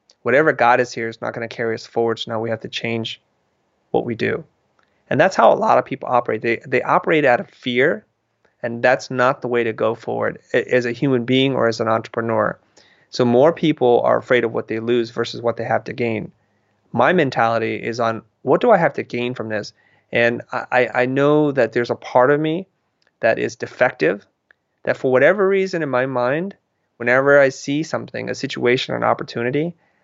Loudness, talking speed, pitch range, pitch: -19 LUFS, 210 wpm, 115-140 Hz, 120 Hz